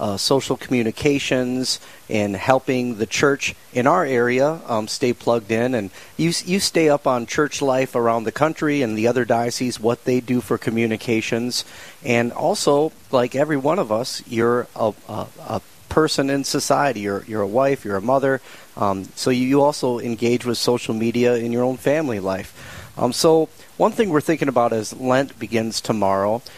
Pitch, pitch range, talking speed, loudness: 125 Hz, 115-140 Hz, 180 wpm, -20 LUFS